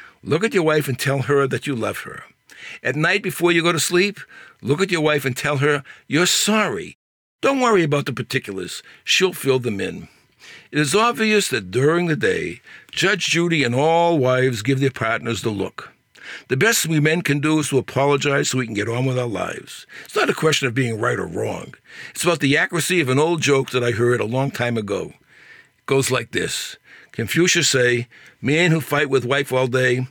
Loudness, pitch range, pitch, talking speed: -19 LUFS, 130-165 Hz, 140 Hz, 215 wpm